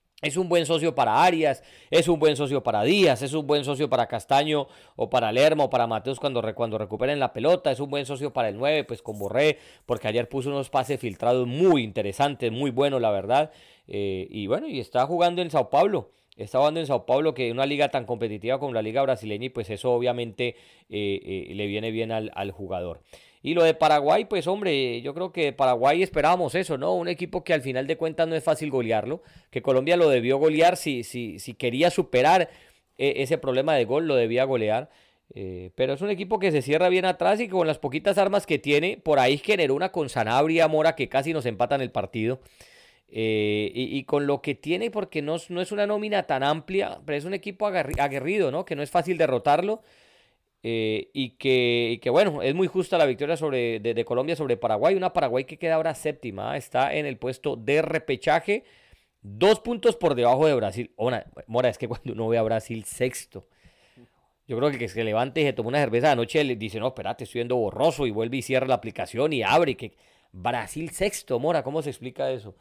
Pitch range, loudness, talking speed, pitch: 120-160 Hz, -25 LUFS, 220 wpm, 140 Hz